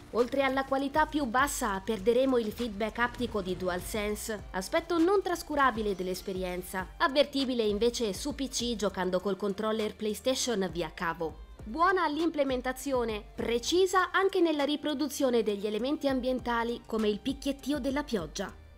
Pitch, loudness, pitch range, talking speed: 240 Hz, -30 LUFS, 210-280 Hz, 125 wpm